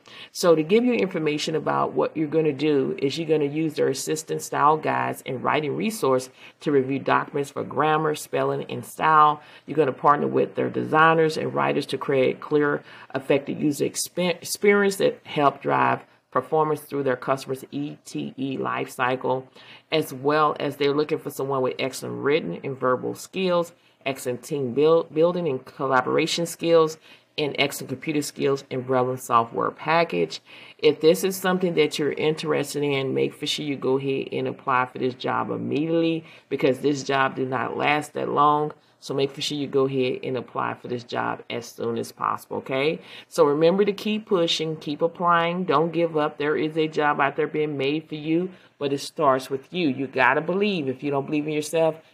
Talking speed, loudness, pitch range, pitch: 190 wpm, -24 LUFS, 135-160 Hz, 150 Hz